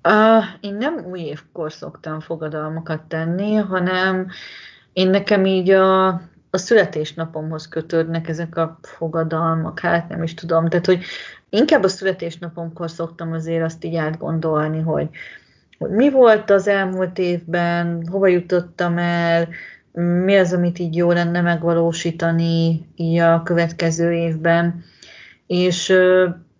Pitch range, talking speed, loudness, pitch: 165-185 Hz, 125 wpm, -19 LUFS, 170 Hz